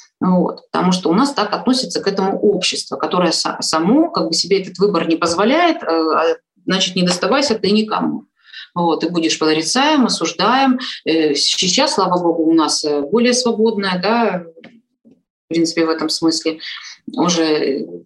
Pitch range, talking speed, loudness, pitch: 165-230 Hz, 145 wpm, -16 LUFS, 185 Hz